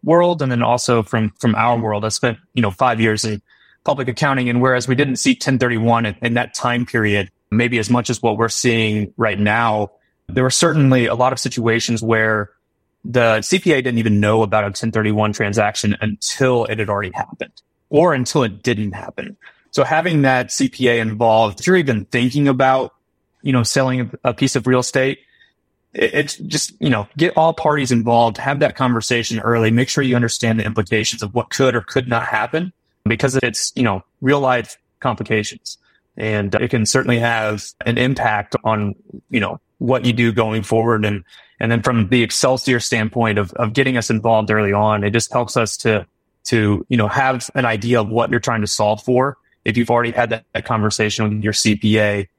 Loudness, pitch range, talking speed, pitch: -17 LUFS, 110-130 Hz, 195 wpm, 115 Hz